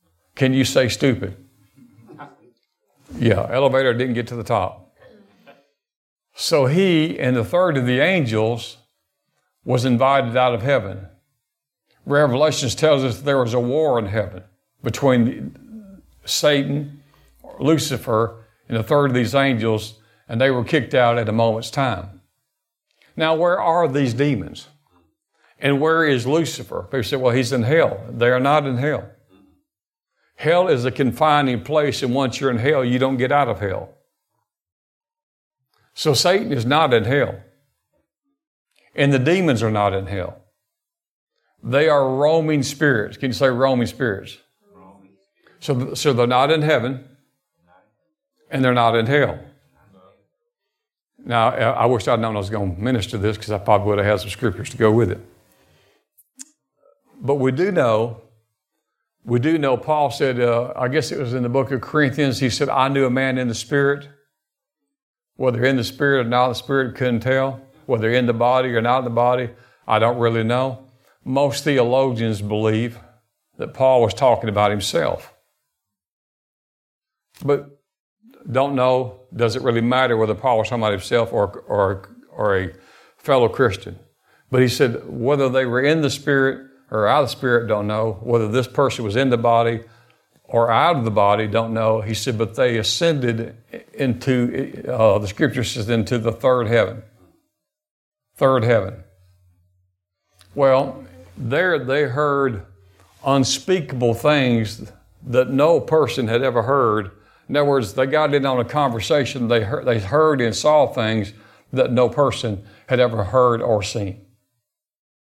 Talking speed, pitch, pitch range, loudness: 155 wpm, 125 Hz, 115-140 Hz, -19 LUFS